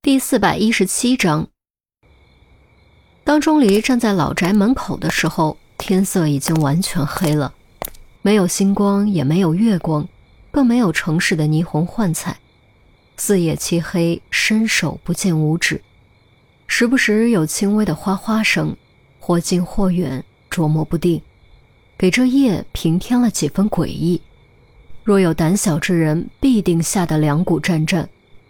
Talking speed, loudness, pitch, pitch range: 205 characters per minute, -17 LUFS, 180 Hz, 160-210 Hz